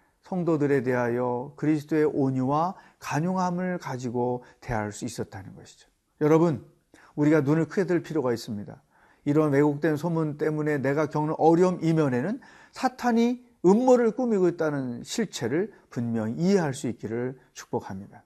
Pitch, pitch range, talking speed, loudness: 150 Hz, 125-175 Hz, 335 characters per minute, -26 LUFS